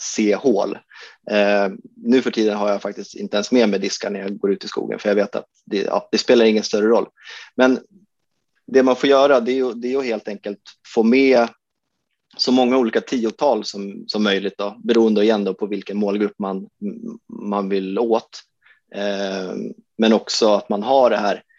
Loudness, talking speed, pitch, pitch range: -19 LUFS, 190 wpm, 110 Hz, 100-130 Hz